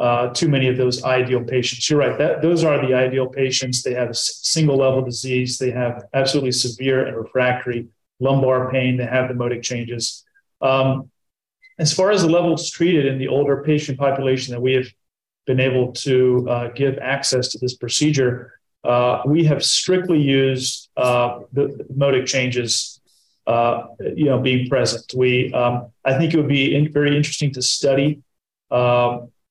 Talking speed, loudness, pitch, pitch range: 175 wpm, -19 LUFS, 130 Hz, 125-140 Hz